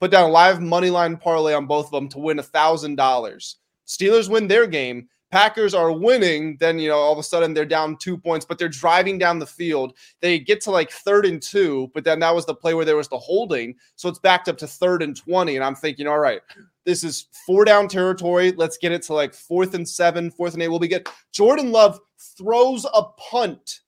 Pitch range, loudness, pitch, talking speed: 155-185 Hz, -19 LUFS, 170 Hz, 235 wpm